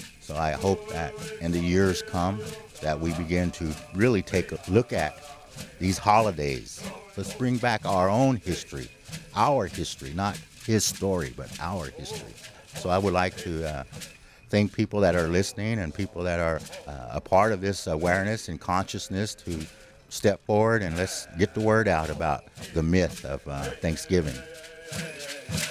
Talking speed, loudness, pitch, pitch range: 165 wpm, -27 LUFS, 95 Hz, 85-105 Hz